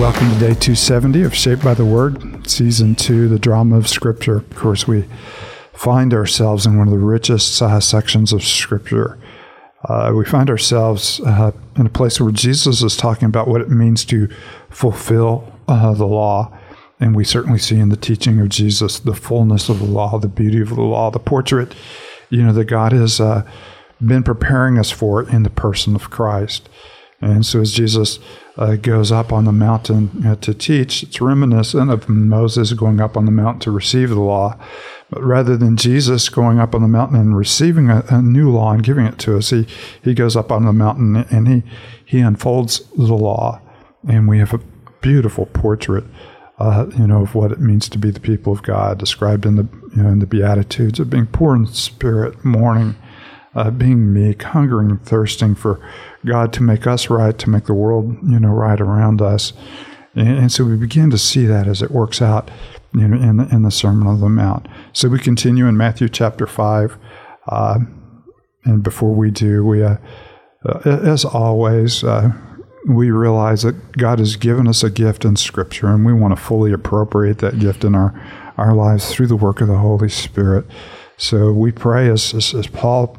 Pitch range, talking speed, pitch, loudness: 105-120 Hz, 200 wpm, 115 Hz, -14 LUFS